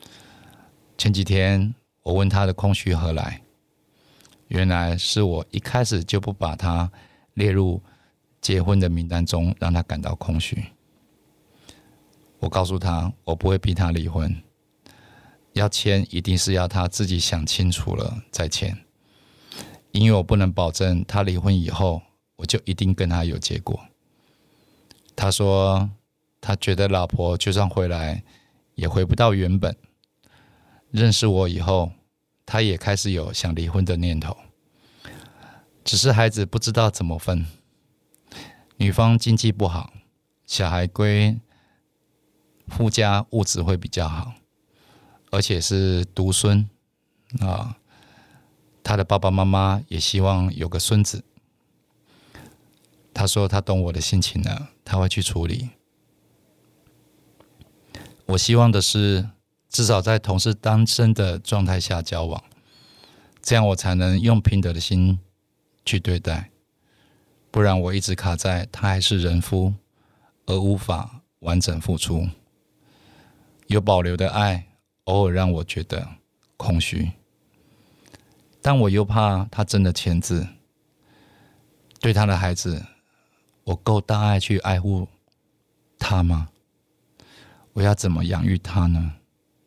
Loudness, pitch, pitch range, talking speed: -22 LUFS, 95 Hz, 90-105 Hz, 180 characters per minute